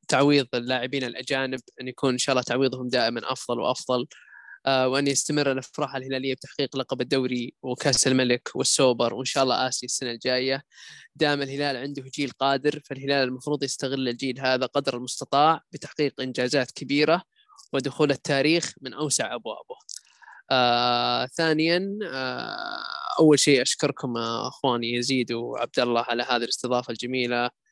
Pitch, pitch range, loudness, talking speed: 135 Hz, 125-145 Hz, -25 LUFS, 140 wpm